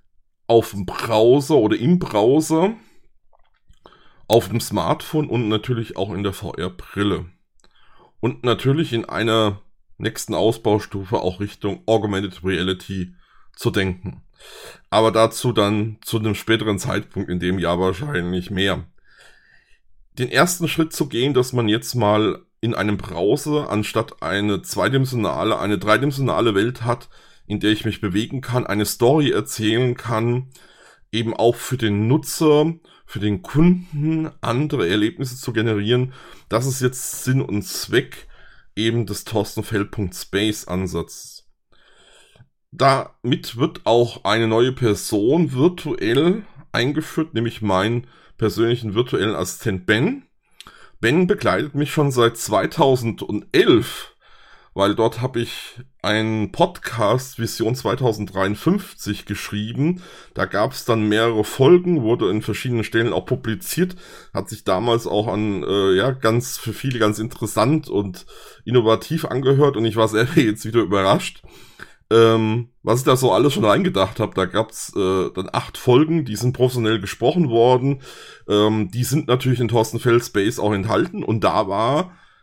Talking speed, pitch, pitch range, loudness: 135 wpm, 115 Hz, 105-130 Hz, -20 LUFS